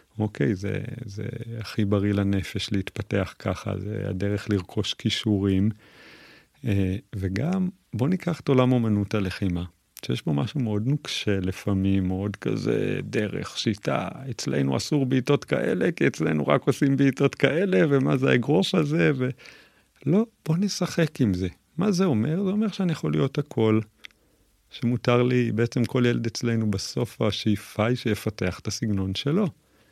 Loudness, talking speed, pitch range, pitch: -25 LUFS, 145 wpm, 100-140 Hz, 110 Hz